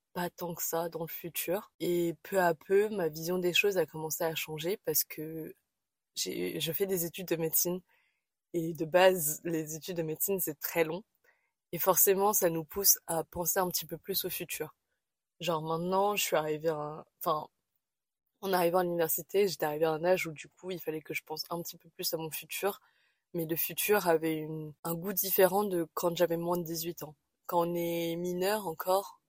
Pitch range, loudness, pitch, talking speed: 160-185 Hz, -31 LUFS, 170 Hz, 210 wpm